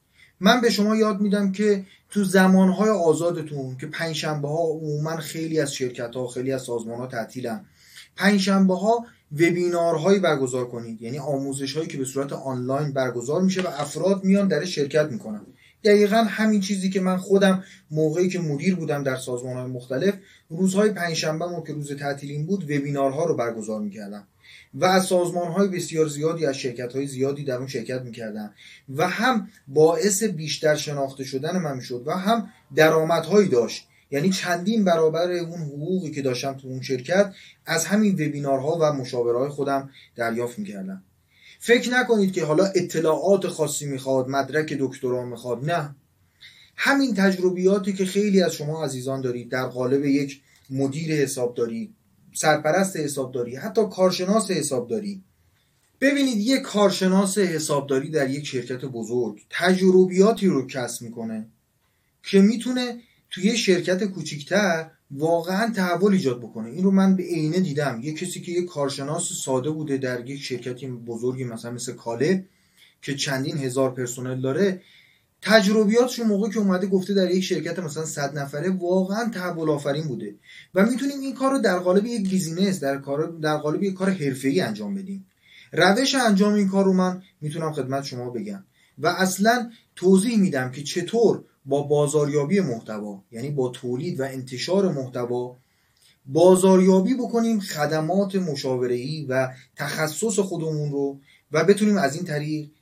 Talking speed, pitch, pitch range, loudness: 155 wpm, 160 Hz, 135-190 Hz, -23 LUFS